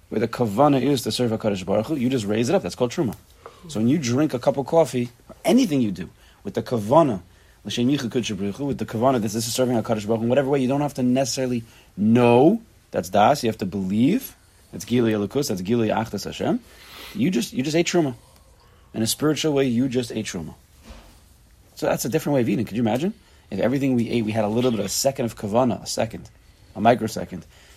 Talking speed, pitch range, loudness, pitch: 230 wpm, 110-135 Hz, -22 LUFS, 120 Hz